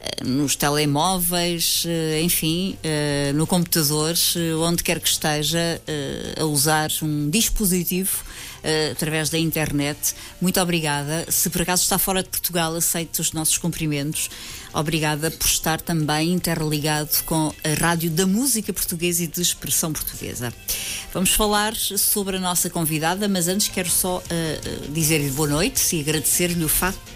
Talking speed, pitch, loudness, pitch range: 135 wpm, 165 Hz, -21 LUFS, 155-180 Hz